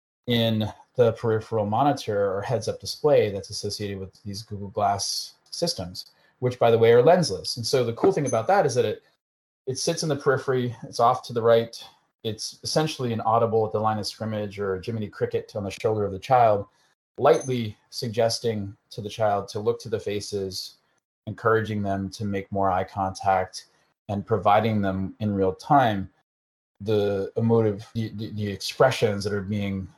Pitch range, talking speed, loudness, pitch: 100-120 Hz, 180 wpm, -24 LUFS, 110 Hz